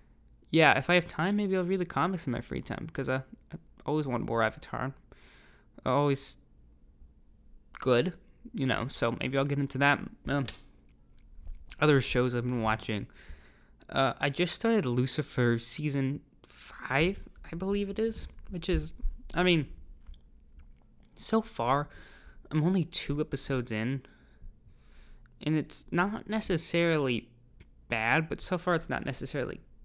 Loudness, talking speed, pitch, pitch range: -30 LUFS, 140 wpm, 135 Hz, 115-170 Hz